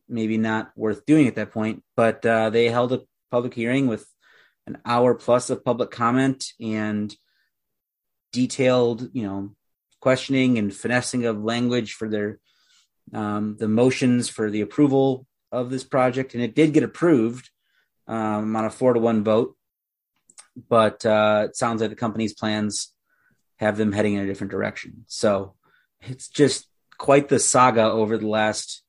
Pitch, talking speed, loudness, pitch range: 115 Hz, 160 wpm, -22 LUFS, 110-125 Hz